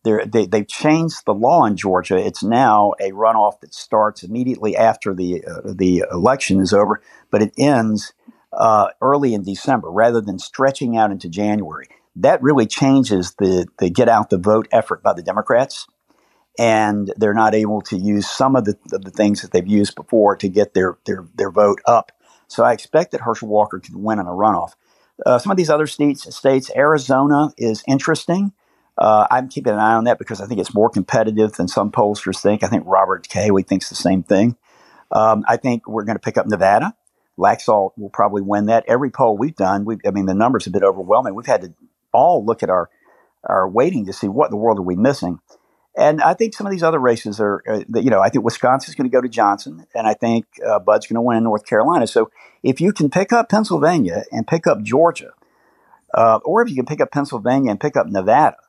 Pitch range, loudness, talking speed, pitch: 100-135 Hz, -17 LUFS, 220 wpm, 110 Hz